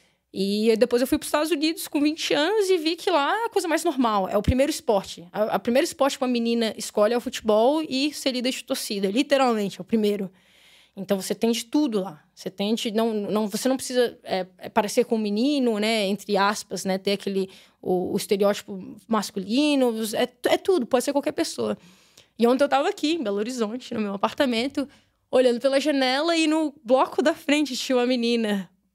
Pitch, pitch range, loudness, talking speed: 240 Hz, 205-285 Hz, -24 LUFS, 210 wpm